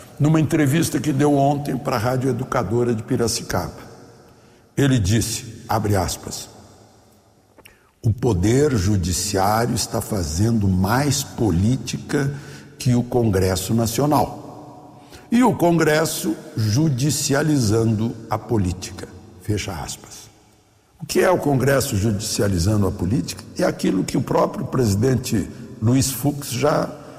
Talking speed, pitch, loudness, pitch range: 115 wpm, 120 Hz, -20 LUFS, 105-145 Hz